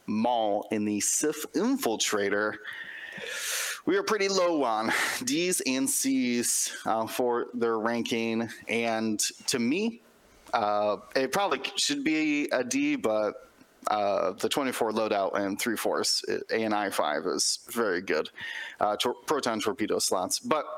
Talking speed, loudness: 140 wpm, -28 LUFS